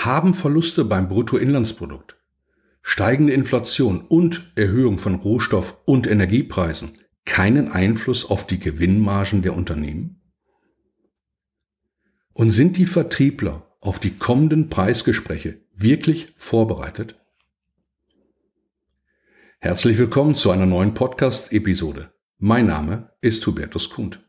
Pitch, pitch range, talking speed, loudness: 110 Hz, 95-135 Hz, 100 wpm, -19 LUFS